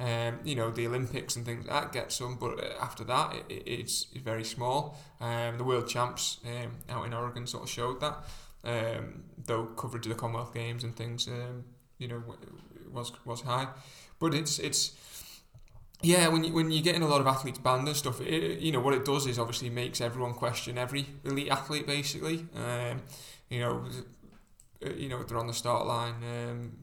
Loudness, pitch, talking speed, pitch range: -32 LUFS, 125 Hz, 205 wpm, 120-140 Hz